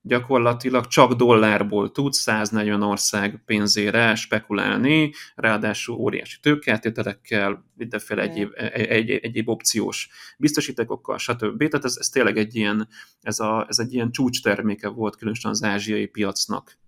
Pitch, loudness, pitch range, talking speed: 110 Hz, -22 LUFS, 105-125 Hz, 135 wpm